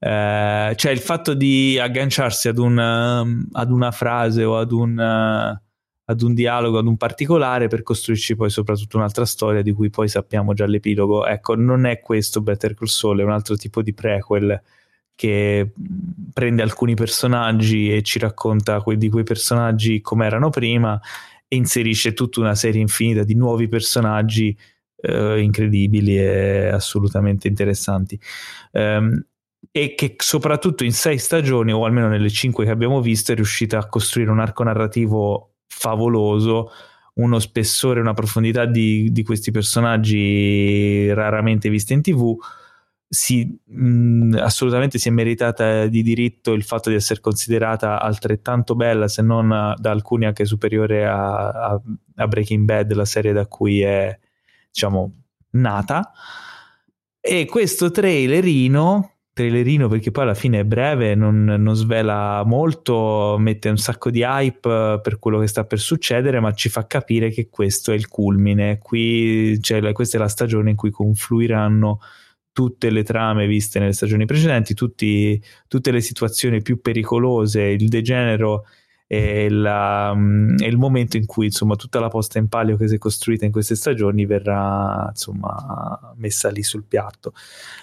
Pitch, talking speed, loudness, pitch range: 110 Hz, 155 wpm, -19 LUFS, 105-120 Hz